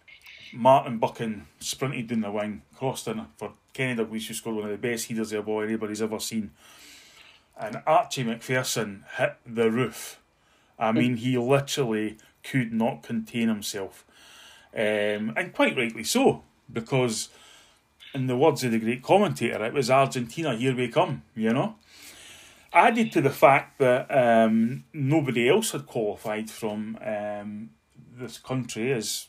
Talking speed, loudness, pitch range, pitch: 150 wpm, -26 LUFS, 110-130 Hz, 115 Hz